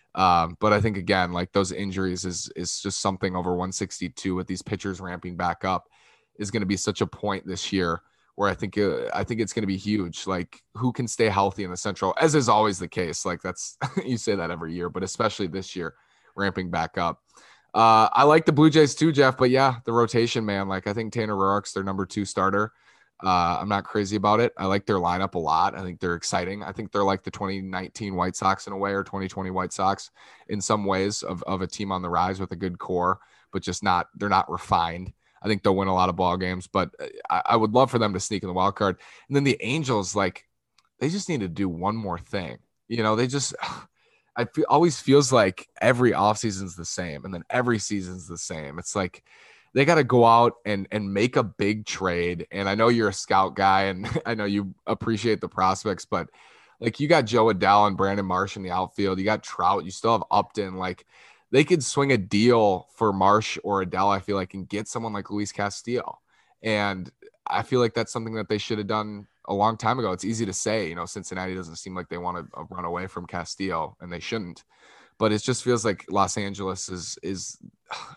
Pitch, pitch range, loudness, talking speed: 100 Hz, 95-115 Hz, -25 LUFS, 235 wpm